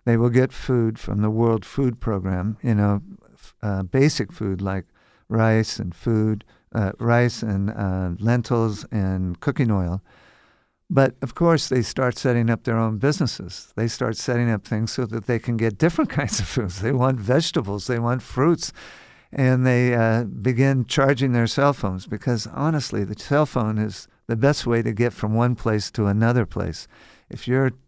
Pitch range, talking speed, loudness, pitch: 105-130 Hz, 180 wpm, -22 LUFS, 115 Hz